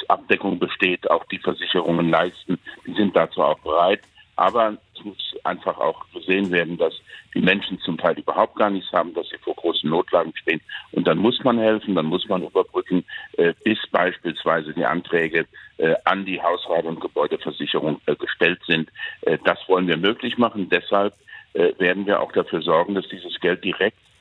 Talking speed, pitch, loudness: 170 wpm, 120 Hz, -22 LUFS